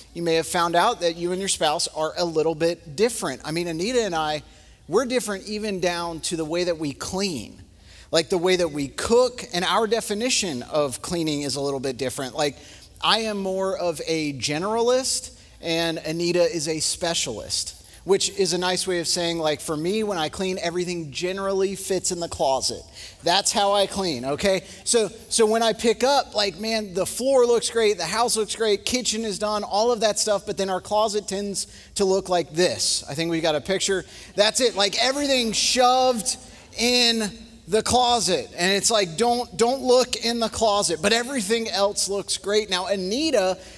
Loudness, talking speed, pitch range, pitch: -23 LUFS, 195 wpm, 170-220 Hz, 190 Hz